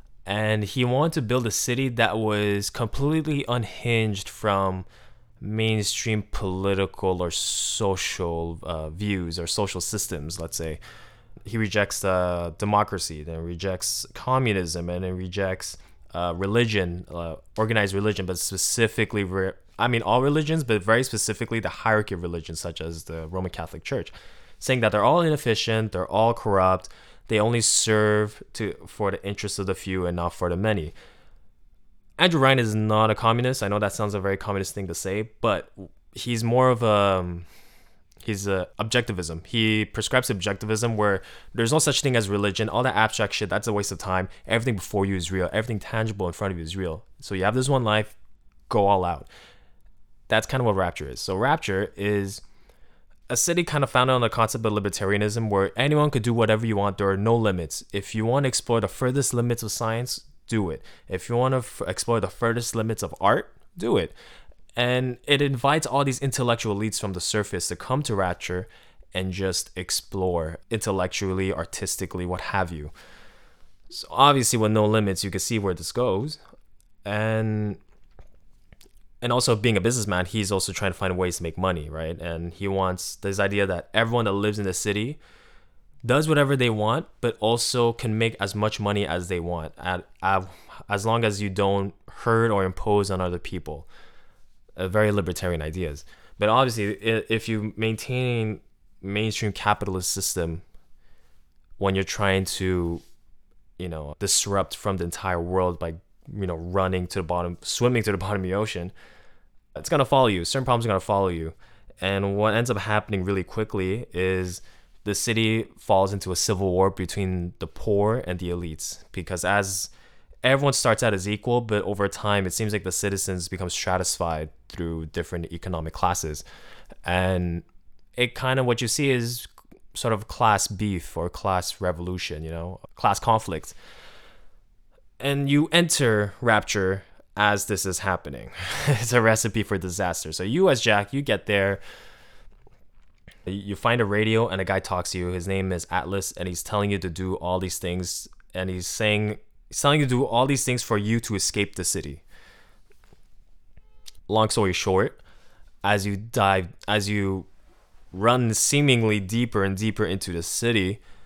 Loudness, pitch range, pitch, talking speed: -25 LUFS, 90-115 Hz, 100 Hz, 175 wpm